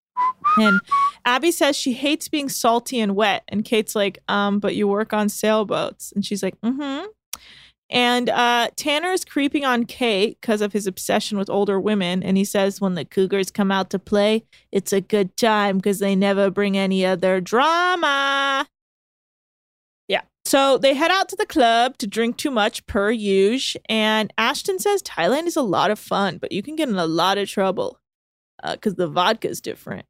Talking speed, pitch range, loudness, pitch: 190 wpm, 200-275 Hz, -20 LUFS, 215 Hz